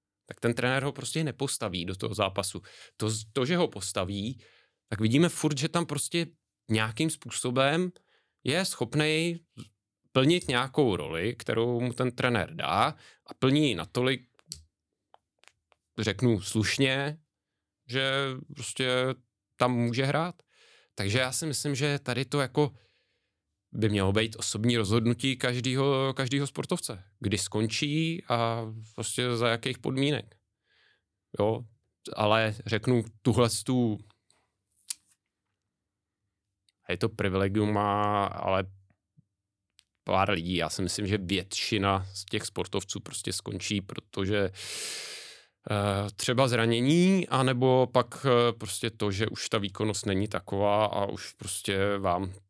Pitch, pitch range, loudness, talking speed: 115 Hz, 100-130 Hz, -29 LUFS, 120 wpm